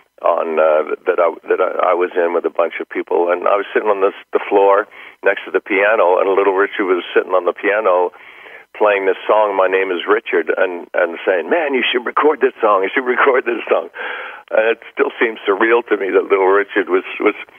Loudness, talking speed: -16 LUFS, 230 wpm